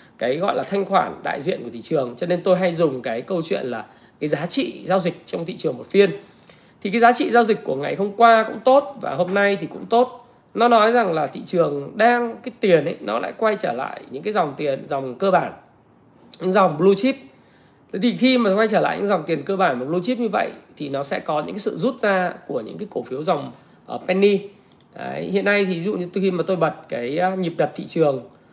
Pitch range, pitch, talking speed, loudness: 180-225 Hz, 200 Hz, 255 wpm, -21 LUFS